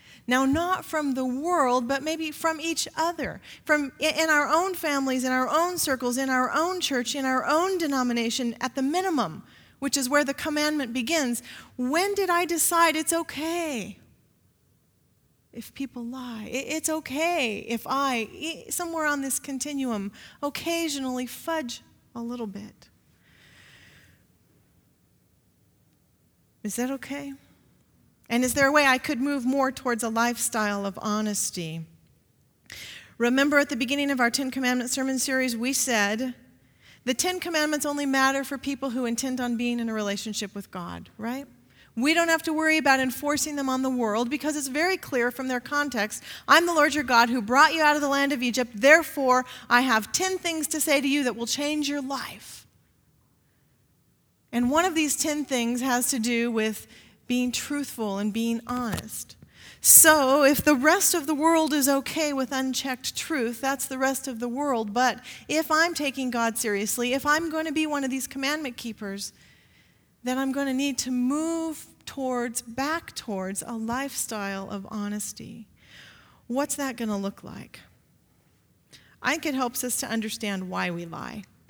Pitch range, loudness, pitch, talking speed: 240-300 Hz, -25 LUFS, 265 Hz, 170 wpm